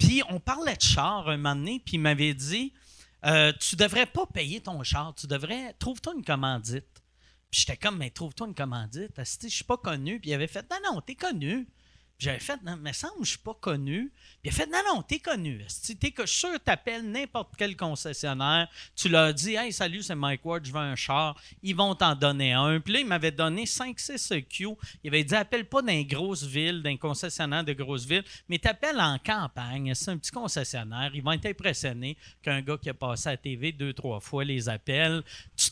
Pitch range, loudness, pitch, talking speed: 140-210 Hz, -28 LUFS, 160 Hz, 225 wpm